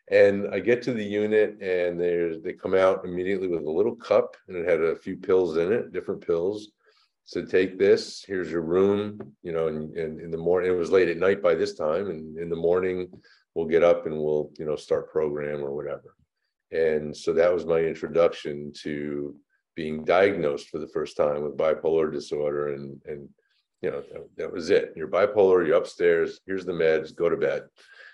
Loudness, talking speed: -25 LUFS, 205 wpm